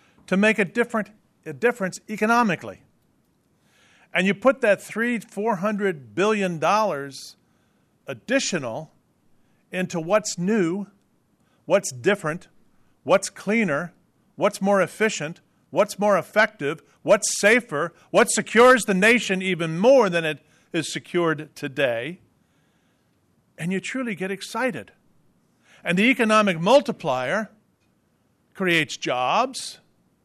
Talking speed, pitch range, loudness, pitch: 105 wpm, 170-220 Hz, -22 LUFS, 200 Hz